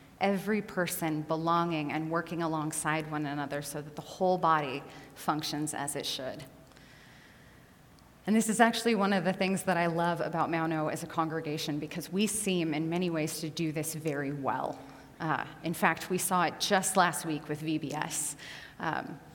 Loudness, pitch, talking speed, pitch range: -31 LUFS, 160 Hz, 175 wpm, 155-180 Hz